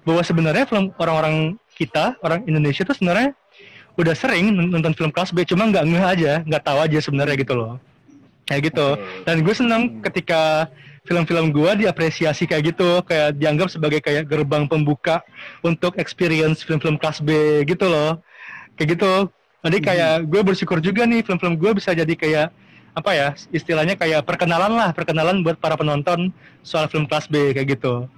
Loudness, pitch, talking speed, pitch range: -19 LUFS, 165 Hz, 165 wpm, 155-180 Hz